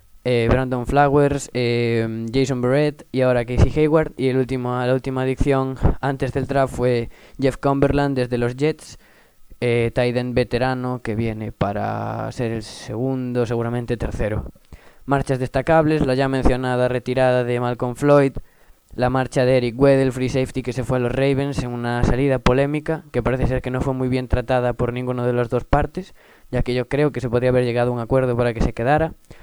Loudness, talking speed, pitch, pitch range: -20 LUFS, 190 wpm, 125 Hz, 120-135 Hz